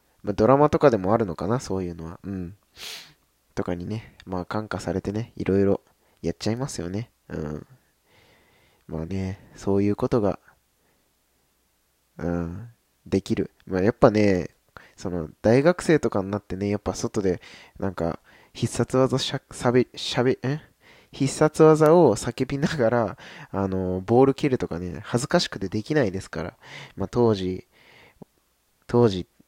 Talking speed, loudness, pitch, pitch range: 285 characters per minute, -24 LUFS, 105 Hz, 90-125 Hz